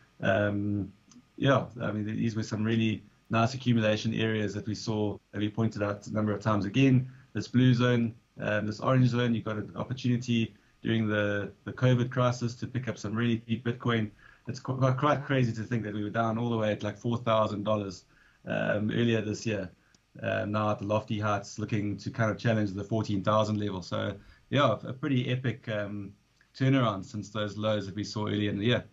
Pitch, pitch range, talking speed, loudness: 110 Hz, 105-120 Hz, 200 wpm, -30 LUFS